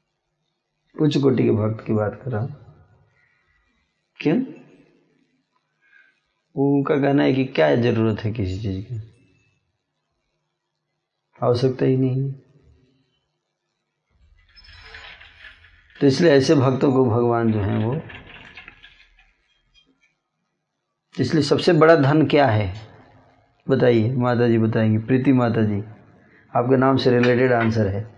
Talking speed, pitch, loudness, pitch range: 105 wpm, 120 Hz, -19 LUFS, 110-135 Hz